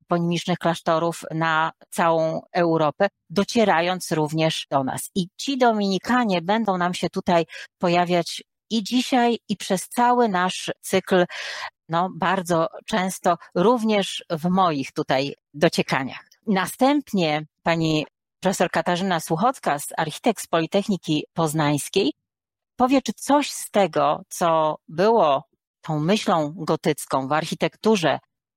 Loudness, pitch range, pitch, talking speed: -22 LUFS, 160-205 Hz, 180 Hz, 110 wpm